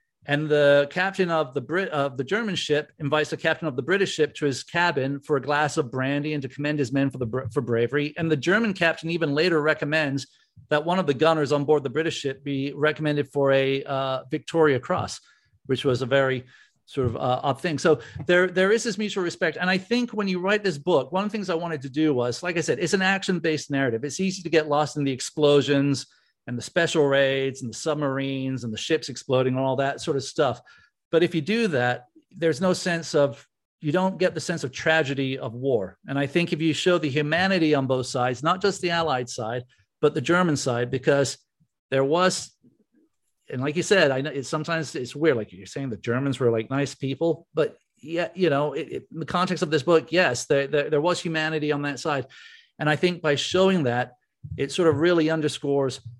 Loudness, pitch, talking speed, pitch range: -24 LUFS, 150 Hz, 230 wpm, 135-170 Hz